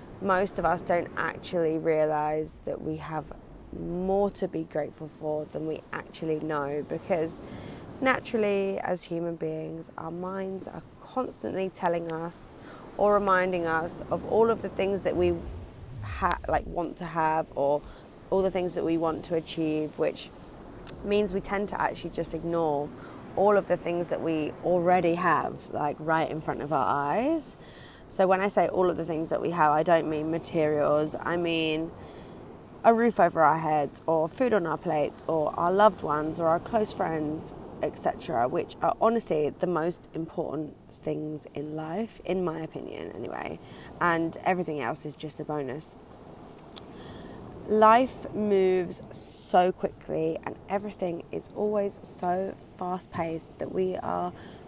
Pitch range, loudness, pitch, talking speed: 155-190 Hz, -28 LUFS, 165 Hz, 160 wpm